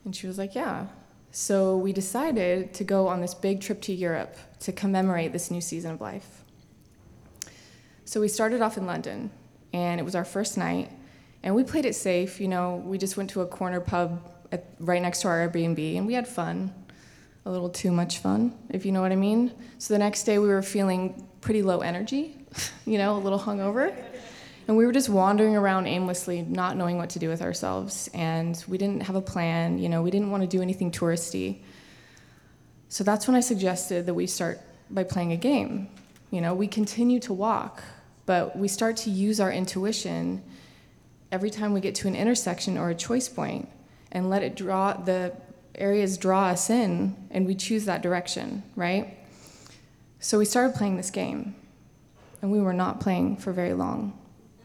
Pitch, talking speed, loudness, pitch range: 190 Hz, 195 wpm, -27 LUFS, 180-210 Hz